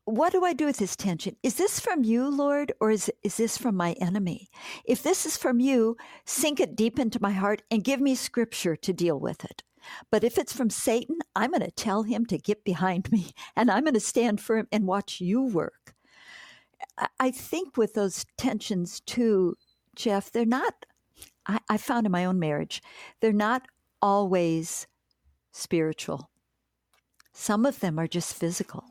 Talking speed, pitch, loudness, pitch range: 185 wpm, 220 Hz, -27 LUFS, 190-255 Hz